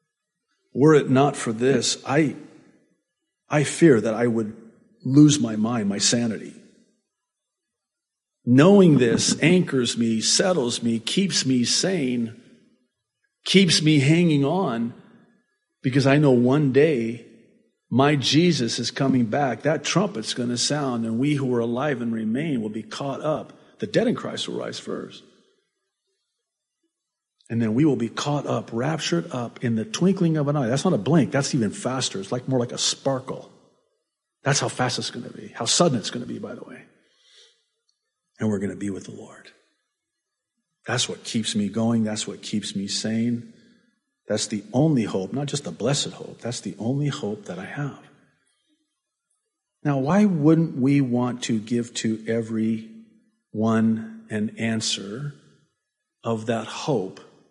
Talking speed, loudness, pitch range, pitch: 160 wpm, -22 LUFS, 115-180 Hz, 135 Hz